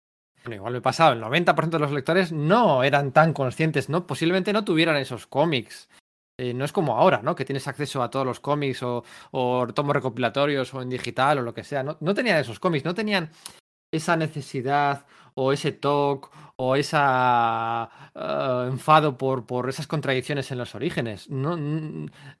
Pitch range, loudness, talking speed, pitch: 125-160 Hz, -24 LUFS, 180 wpm, 140 Hz